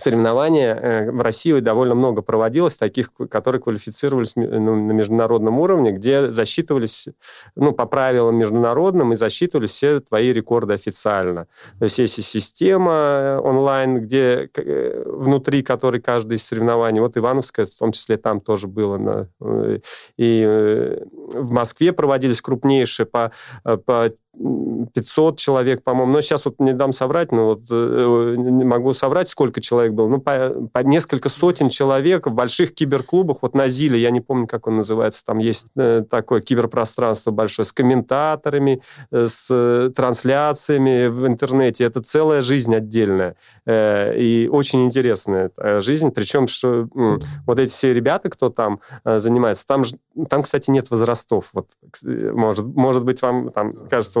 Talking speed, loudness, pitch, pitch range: 140 wpm, -18 LUFS, 125 Hz, 115-135 Hz